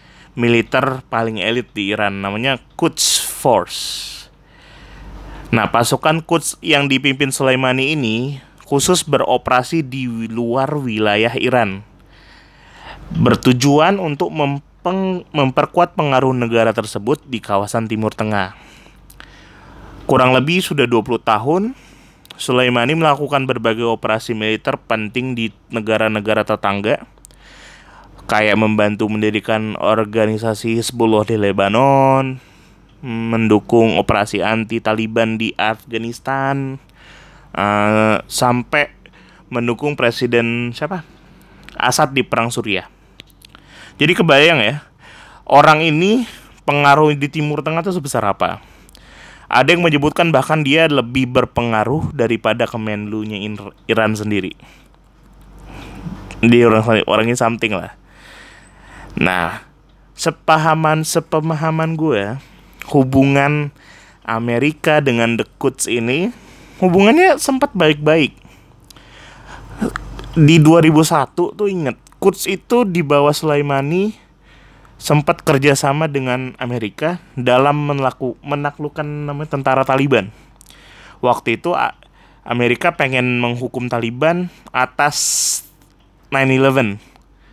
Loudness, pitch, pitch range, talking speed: -16 LUFS, 130 Hz, 115-150 Hz, 95 wpm